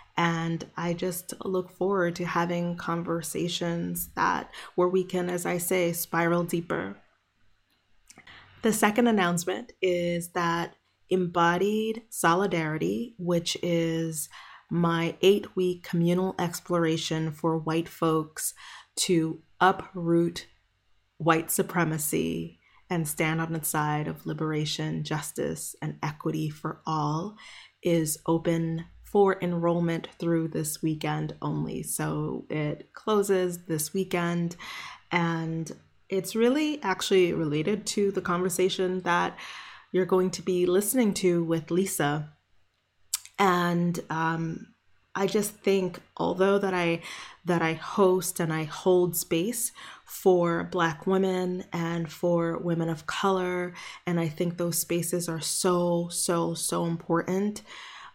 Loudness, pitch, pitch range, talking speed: -27 LUFS, 170 Hz, 165-185 Hz, 115 wpm